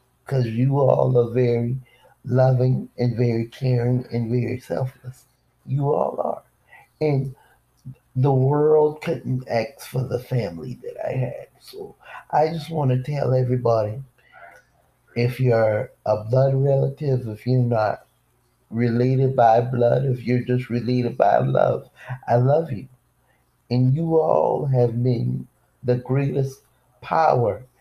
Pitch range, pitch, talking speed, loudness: 120-135 Hz, 125 Hz, 130 wpm, -22 LUFS